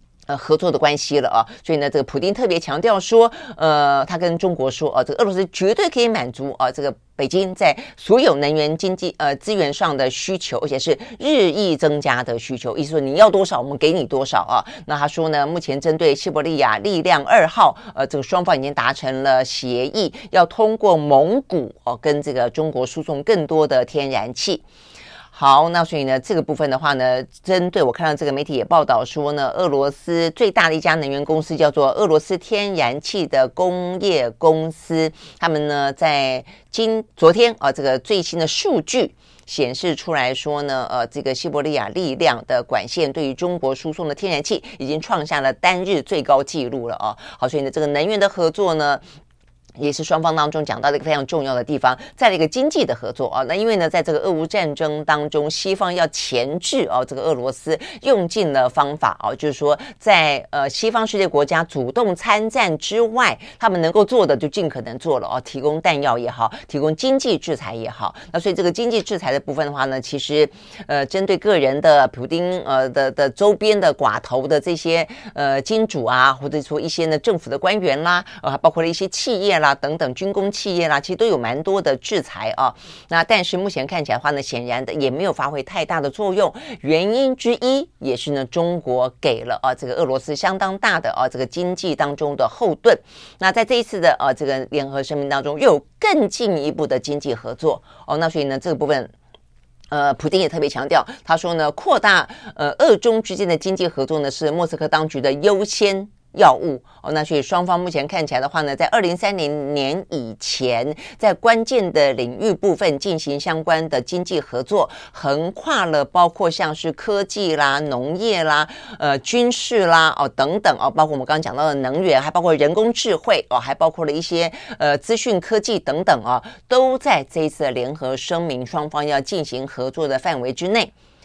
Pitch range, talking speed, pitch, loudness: 140-185 Hz, 305 characters per minute, 155 Hz, -19 LUFS